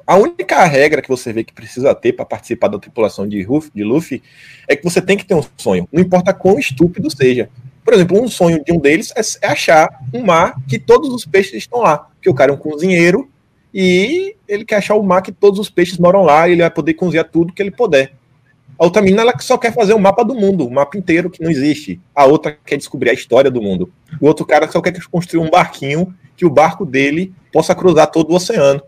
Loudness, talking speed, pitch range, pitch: -13 LUFS, 245 wpm, 145-195 Hz, 170 Hz